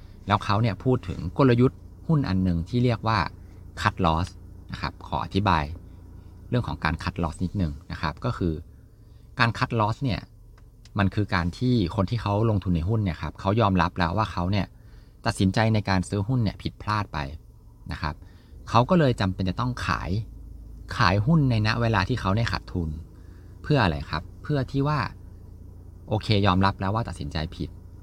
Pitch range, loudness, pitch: 90-110 Hz, -25 LUFS, 95 Hz